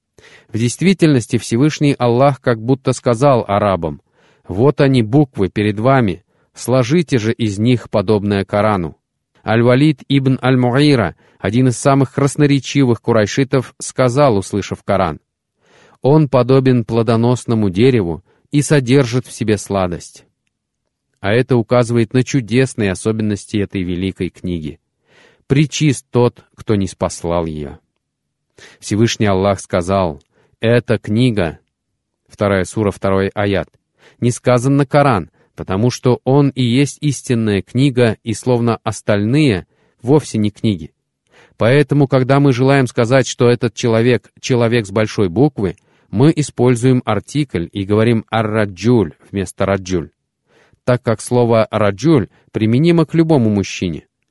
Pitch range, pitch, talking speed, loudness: 100-135 Hz, 120 Hz, 120 wpm, -15 LUFS